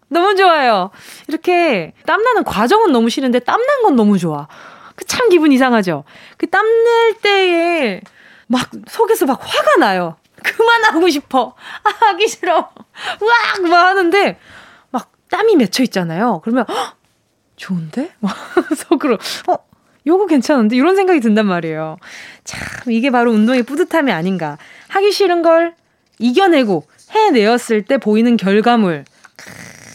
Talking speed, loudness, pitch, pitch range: 275 characters per minute, -14 LUFS, 285 Hz, 220-370 Hz